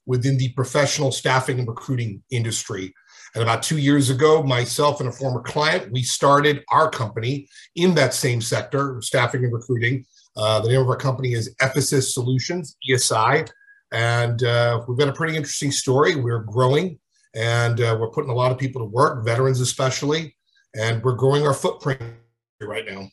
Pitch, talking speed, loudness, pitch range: 130 Hz, 175 wpm, -21 LUFS, 120-145 Hz